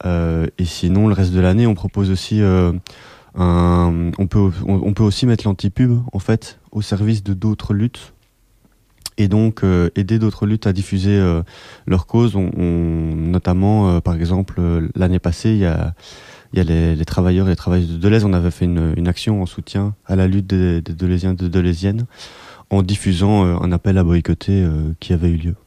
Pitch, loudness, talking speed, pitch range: 95 Hz, -17 LUFS, 205 wpm, 85-105 Hz